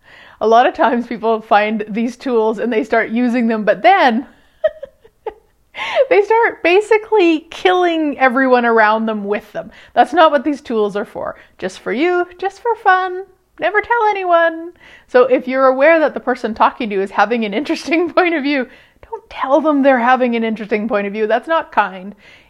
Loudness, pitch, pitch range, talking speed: -15 LUFS, 265 Hz, 225-340 Hz, 185 wpm